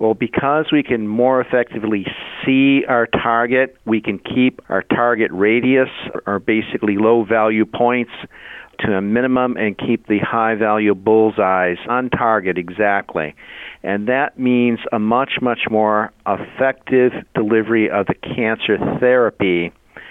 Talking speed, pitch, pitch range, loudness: 135 wpm, 115 Hz, 105-125 Hz, -17 LUFS